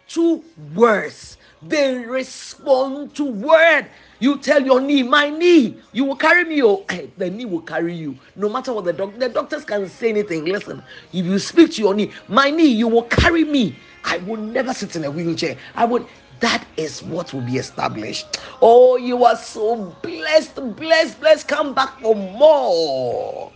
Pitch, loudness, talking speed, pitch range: 245 Hz, -18 LUFS, 185 wpm, 200-290 Hz